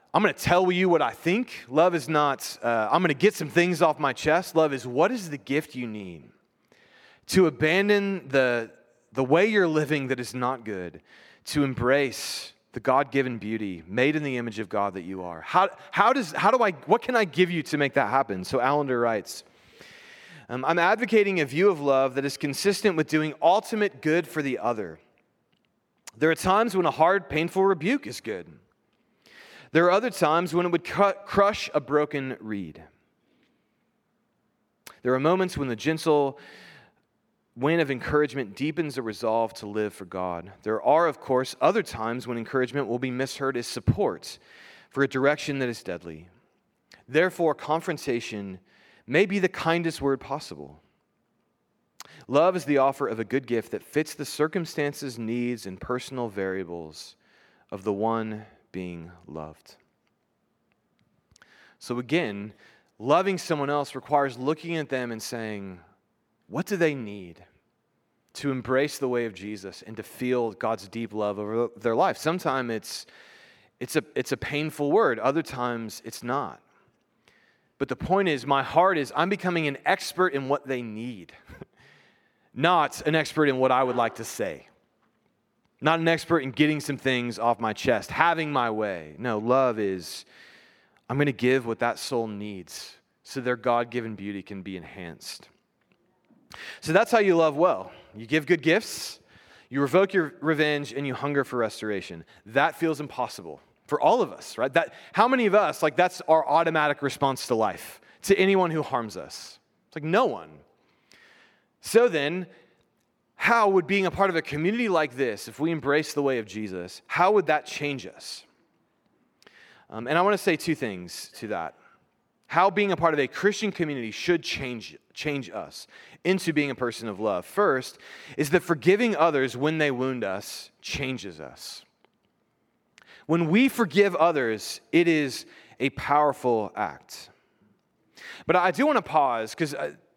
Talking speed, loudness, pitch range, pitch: 170 wpm, -25 LUFS, 115-165 Hz, 140 Hz